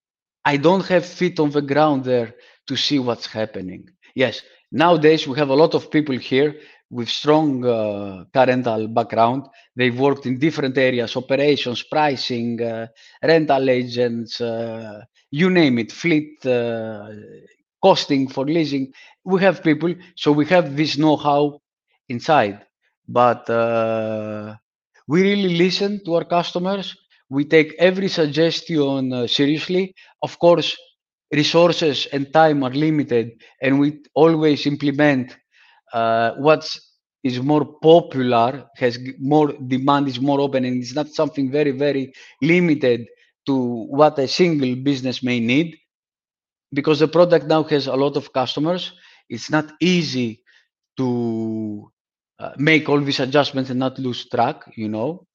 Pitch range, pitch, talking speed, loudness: 125-155 Hz, 140 Hz, 140 wpm, -19 LUFS